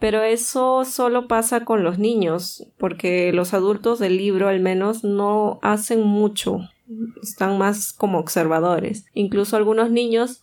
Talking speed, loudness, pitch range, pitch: 140 wpm, -20 LUFS, 190-225 Hz, 210 Hz